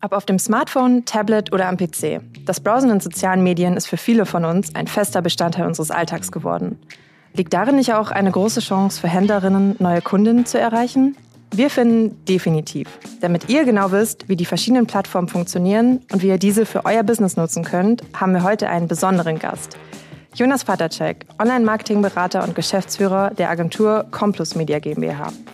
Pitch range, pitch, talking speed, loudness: 175-220 Hz, 195 Hz, 175 wpm, -18 LUFS